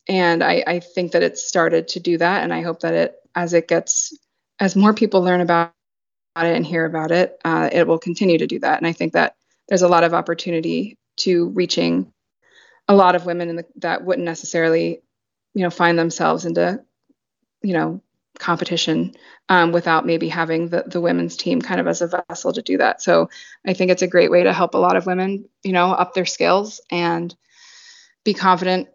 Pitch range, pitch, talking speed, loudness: 165-185 Hz, 175 Hz, 205 wpm, -19 LUFS